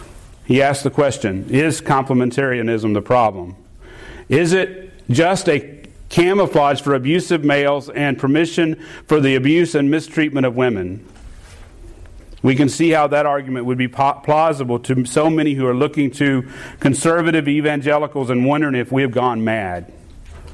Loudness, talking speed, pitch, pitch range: -17 LUFS, 150 wpm, 135 Hz, 120-150 Hz